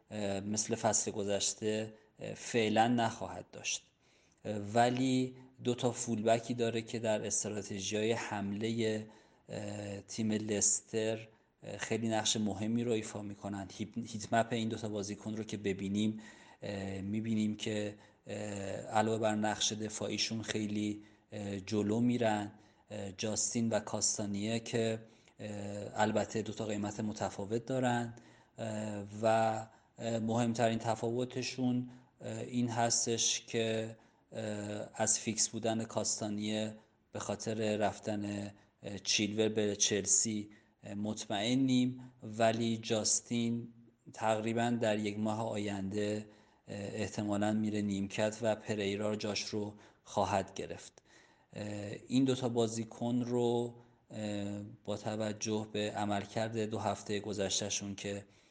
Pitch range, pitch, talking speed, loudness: 105-115 Hz, 110 Hz, 100 wpm, -35 LUFS